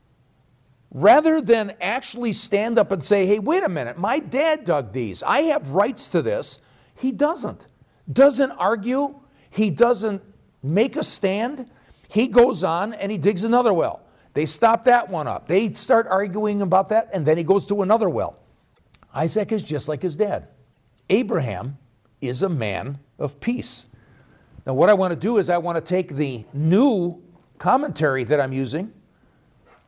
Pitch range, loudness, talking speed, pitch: 155-230 Hz, -21 LUFS, 165 wpm, 195 Hz